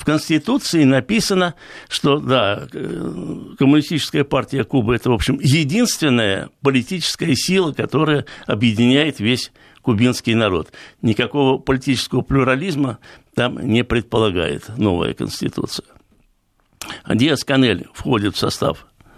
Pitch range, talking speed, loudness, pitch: 120-150 Hz, 105 wpm, -18 LUFS, 135 Hz